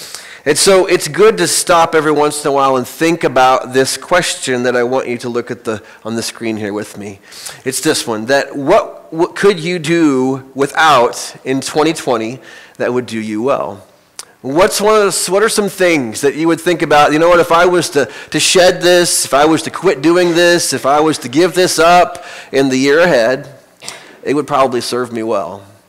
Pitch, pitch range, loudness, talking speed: 150 Hz, 130-175 Hz, -12 LUFS, 220 wpm